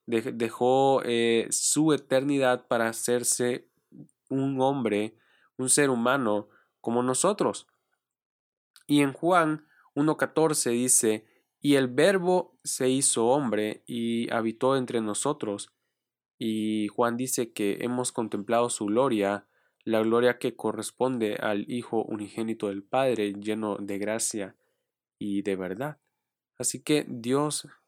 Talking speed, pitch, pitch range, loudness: 115 wpm, 120 Hz, 110-135 Hz, -27 LUFS